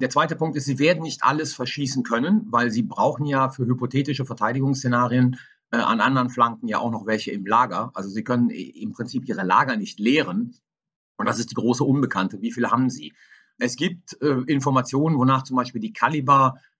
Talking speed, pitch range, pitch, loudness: 195 wpm, 120-145 Hz, 130 Hz, -22 LUFS